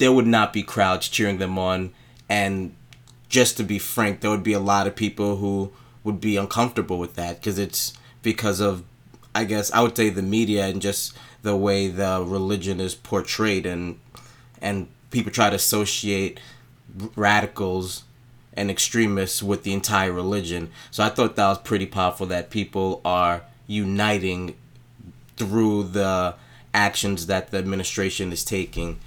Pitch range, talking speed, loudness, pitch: 95-115 Hz, 160 wpm, -23 LUFS, 100 Hz